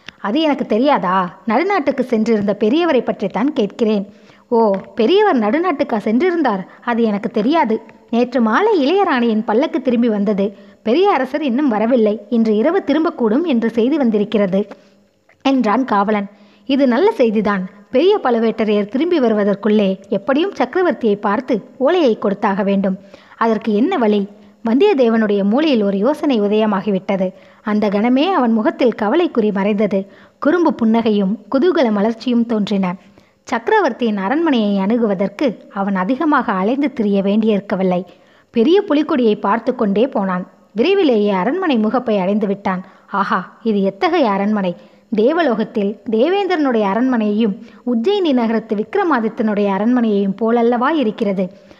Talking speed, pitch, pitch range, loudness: 110 wpm, 225 Hz, 205-265 Hz, -16 LUFS